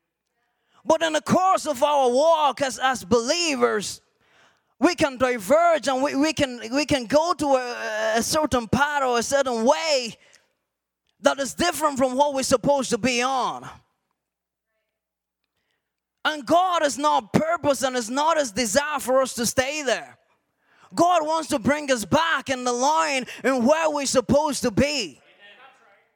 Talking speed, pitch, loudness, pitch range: 160 wpm, 280 Hz, -22 LUFS, 255-305 Hz